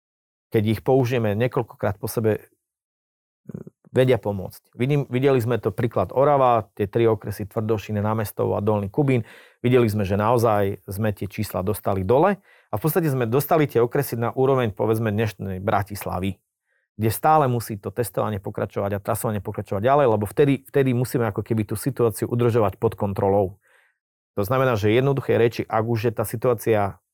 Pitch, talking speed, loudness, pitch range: 115 Hz, 165 wpm, -22 LUFS, 105-125 Hz